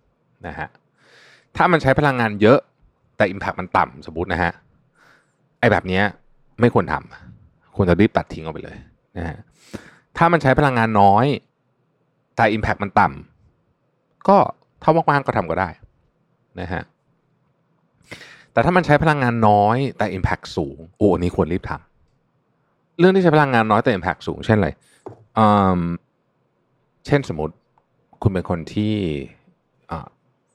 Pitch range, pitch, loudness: 95-140 Hz, 110 Hz, -19 LUFS